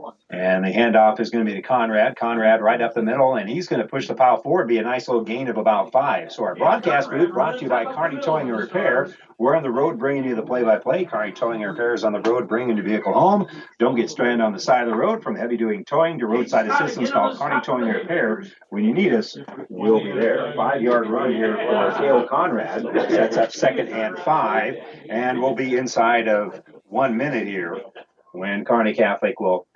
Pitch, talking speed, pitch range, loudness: 115 Hz, 230 wpm, 110-125 Hz, -20 LUFS